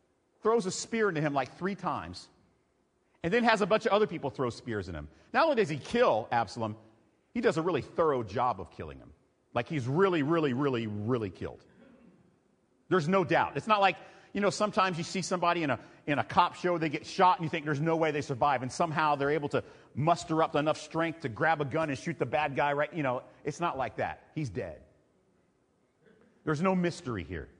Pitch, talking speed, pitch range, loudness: 160 Hz, 220 wpm, 135-185 Hz, -30 LUFS